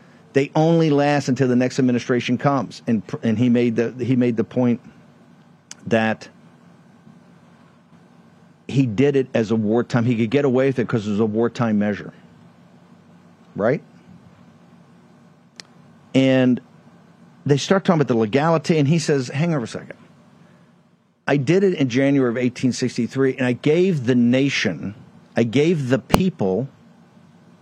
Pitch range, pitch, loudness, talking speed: 120-145 Hz, 130 Hz, -20 LUFS, 145 wpm